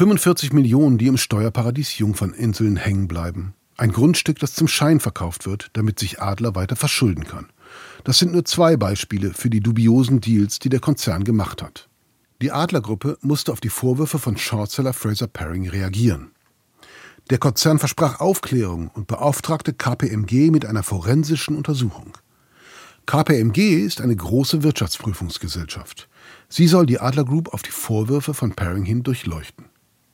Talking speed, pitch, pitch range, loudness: 145 wpm, 120 Hz, 105-145 Hz, -20 LUFS